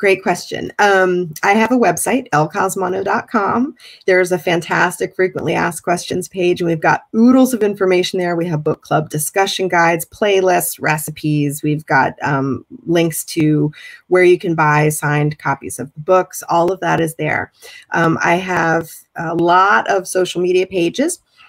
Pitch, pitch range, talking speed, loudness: 175 Hz, 155-190 Hz, 160 wpm, -16 LUFS